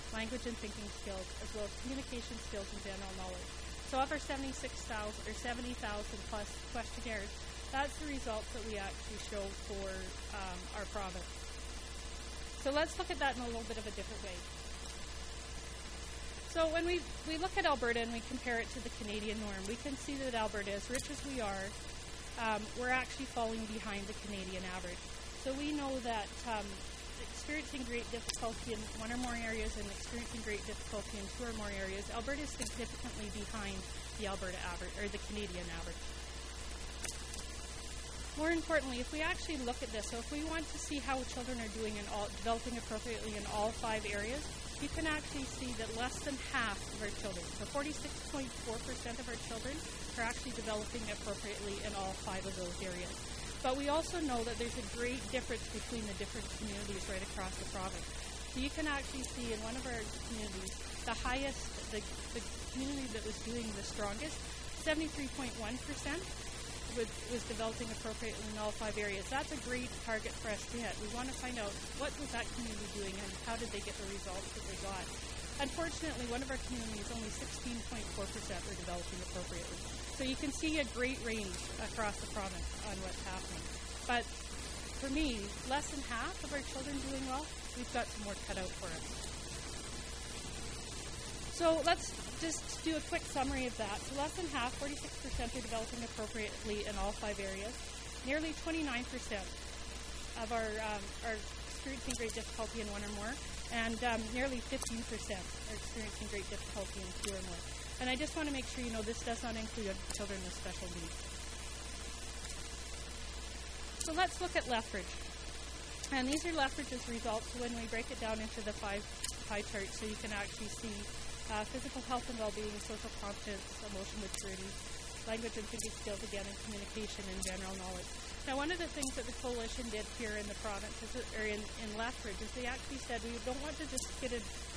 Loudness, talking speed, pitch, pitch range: -40 LUFS, 185 wpm, 230 Hz, 210-265 Hz